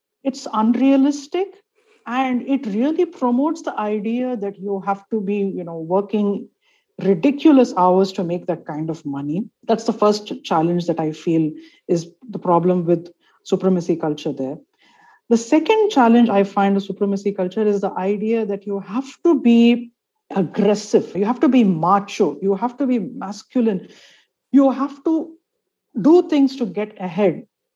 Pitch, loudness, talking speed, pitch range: 215 Hz, -19 LUFS, 160 wpm, 190-270 Hz